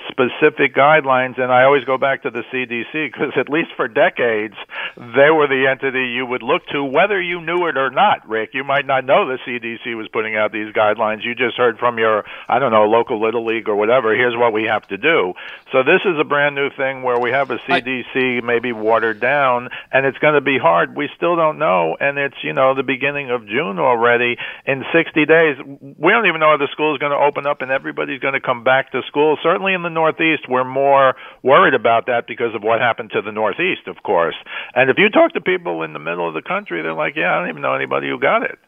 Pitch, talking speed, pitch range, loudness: 130 Hz, 245 wpm, 120-145 Hz, -17 LUFS